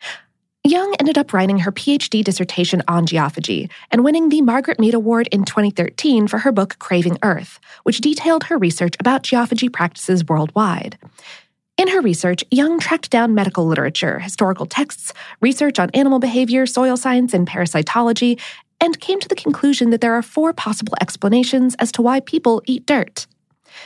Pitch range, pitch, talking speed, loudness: 190-280 Hz, 235 Hz, 165 wpm, -17 LUFS